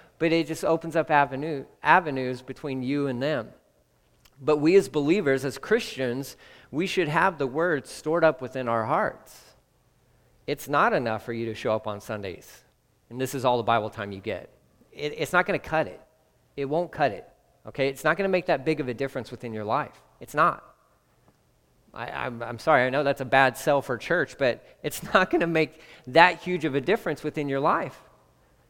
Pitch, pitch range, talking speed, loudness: 140 Hz, 125-160 Hz, 205 wpm, -25 LUFS